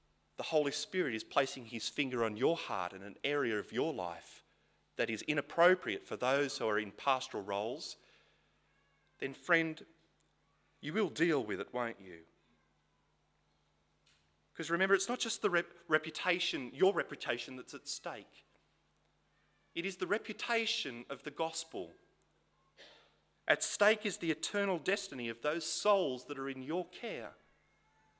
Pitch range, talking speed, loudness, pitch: 125-185 Hz, 145 wpm, -35 LUFS, 160 Hz